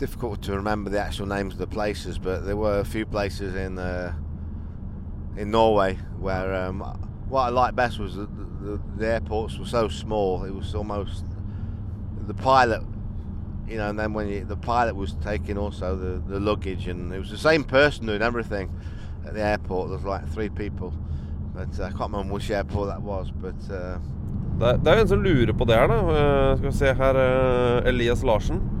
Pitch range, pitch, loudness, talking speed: 95-105 Hz, 100 Hz, -25 LUFS, 170 wpm